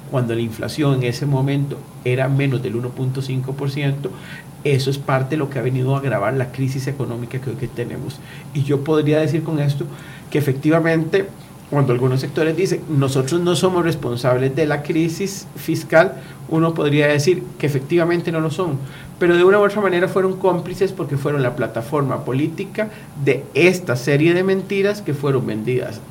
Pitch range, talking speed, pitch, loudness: 130-165 Hz, 175 wpm, 145 Hz, -19 LUFS